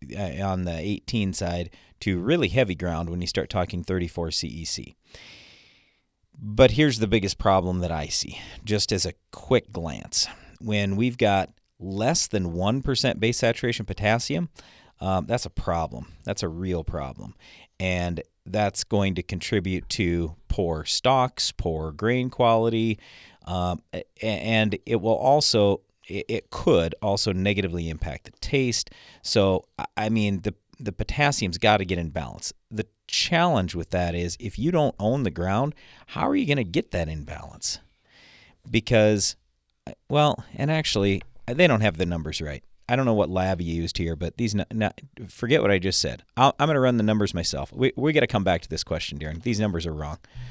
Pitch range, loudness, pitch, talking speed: 85-115 Hz, -25 LUFS, 100 Hz, 175 wpm